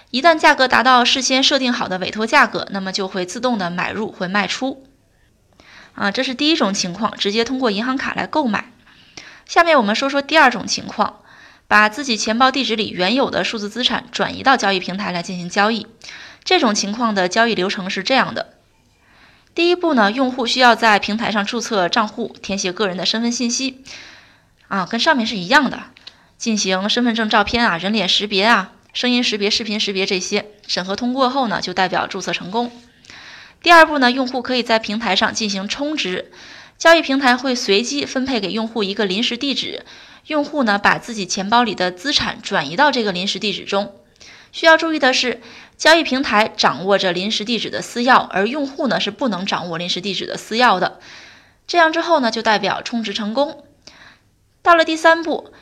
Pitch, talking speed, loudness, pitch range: 230 Hz, 300 characters per minute, -17 LUFS, 200-265 Hz